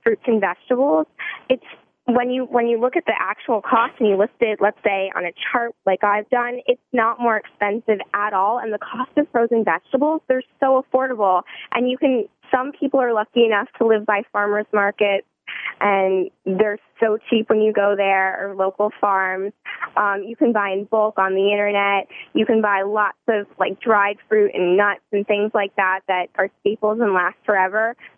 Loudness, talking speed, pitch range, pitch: -20 LUFS, 200 wpm, 200-235 Hz, 210 Hz